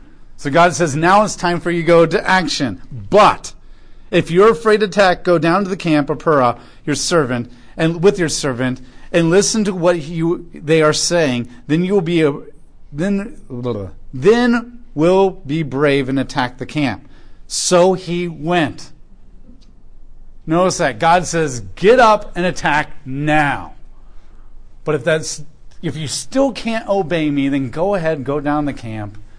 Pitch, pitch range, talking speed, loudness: 165 Hz, 140-185 Hz, 165 wpm, -16 LUFS